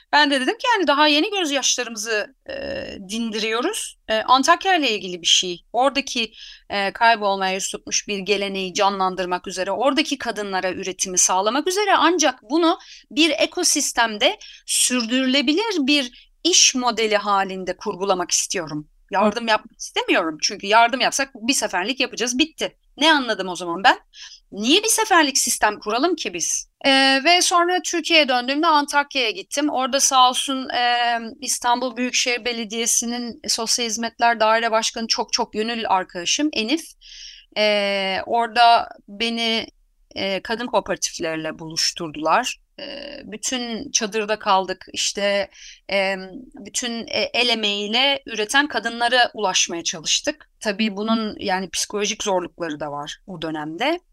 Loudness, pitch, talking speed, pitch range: -20 LUFS, 235 Hz, 130 wpm, 205-285 Hz